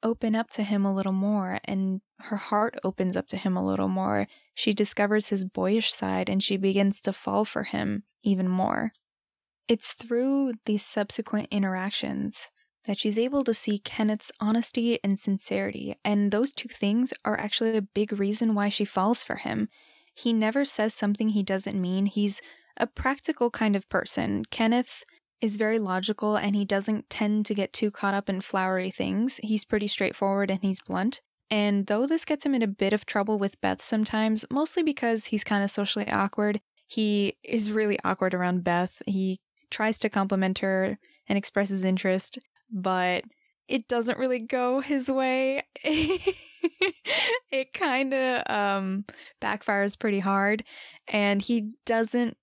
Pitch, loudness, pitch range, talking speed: 210 Hz, -27 LUFS, 195-235 Hz, 165 wpm